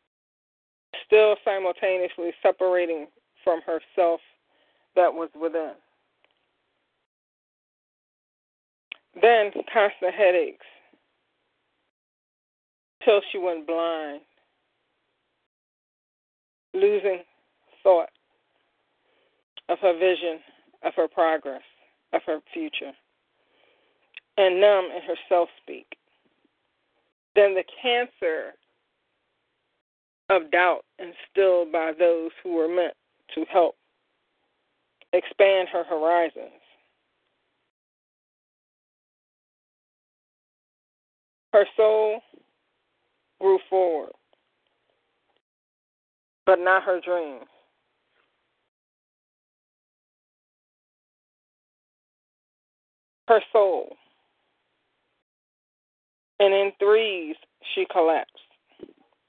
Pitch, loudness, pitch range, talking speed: 185 Hz, -23 LUFS, 170-215 Hz, 65 wpm